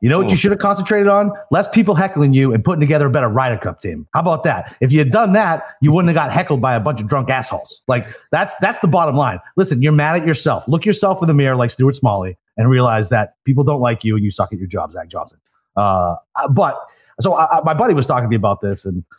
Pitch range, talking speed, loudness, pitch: 115-165 Hz, 270 wpm, -16 LUFS, 135 Hz